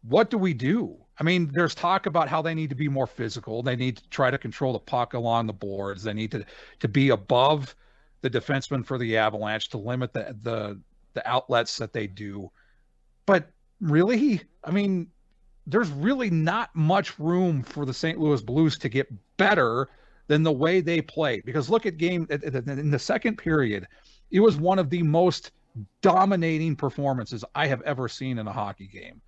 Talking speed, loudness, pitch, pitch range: 190 wpm, -25 LUFS, 145 Hz, 120-170 Hz